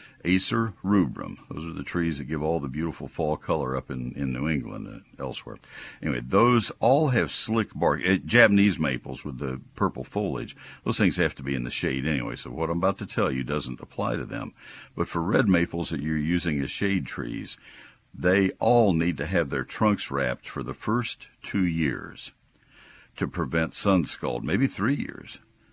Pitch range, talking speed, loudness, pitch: 70-95 Hz, 195 wpm, -26 LUFS, 80 Hz